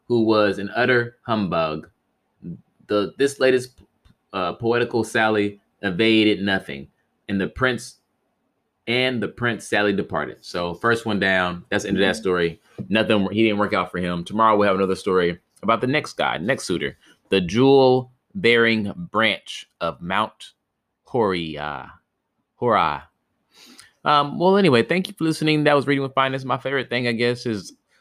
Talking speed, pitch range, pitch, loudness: 160 wpm, 95-125 Hz, 110 Hz, -21 LUFS